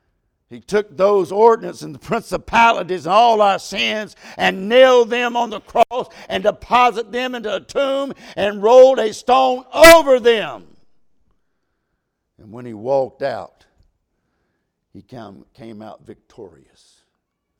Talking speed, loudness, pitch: 130 wpm, -15 LUFS, 210 Hz